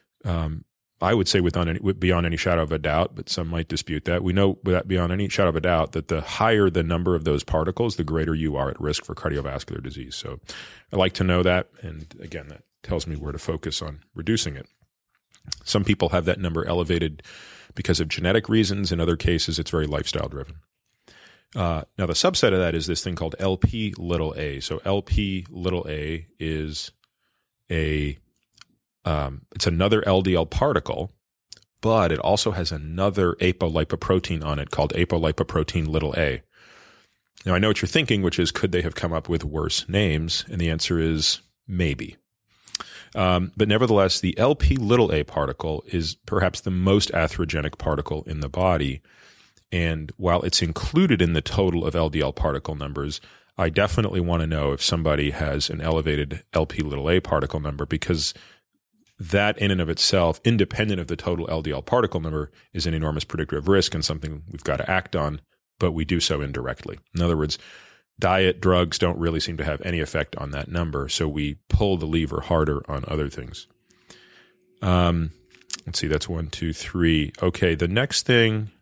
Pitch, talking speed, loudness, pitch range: 85 Hz, 185 wpm, -24 LUFS, 75-90 Hz